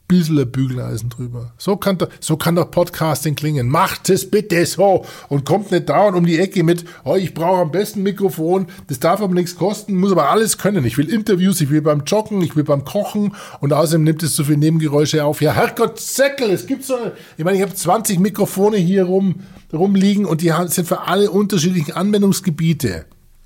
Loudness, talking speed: -17 LUFS, 205 wpm